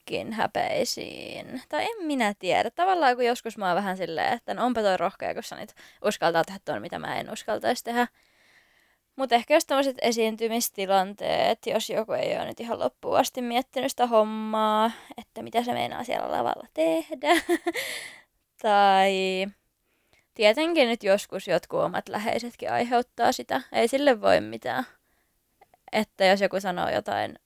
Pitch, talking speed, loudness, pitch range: 235 Hz, 150 wpm, -26 LUFS, 200-275 Hz